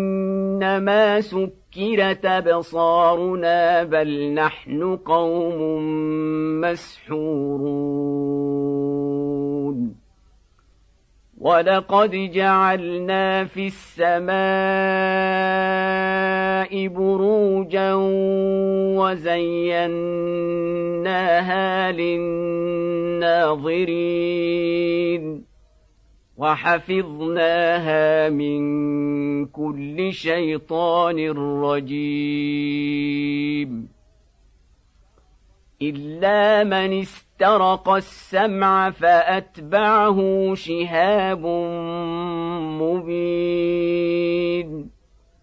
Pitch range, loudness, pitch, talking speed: 150-190 Hz, -20 LUFS, 170 Hz, 35 wpm